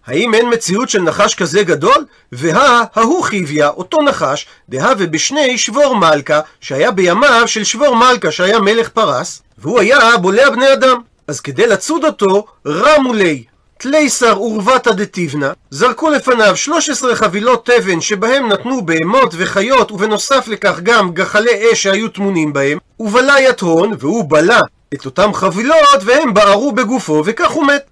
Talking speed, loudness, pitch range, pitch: 145 wpm, -11 LUFS, 190-260 Hz, 225 Hz